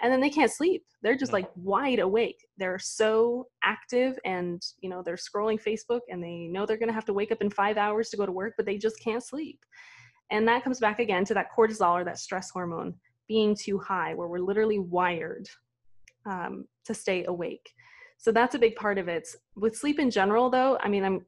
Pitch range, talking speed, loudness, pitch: 185-240 Hz, 220 wpm, -28 LUFS, 215 Hz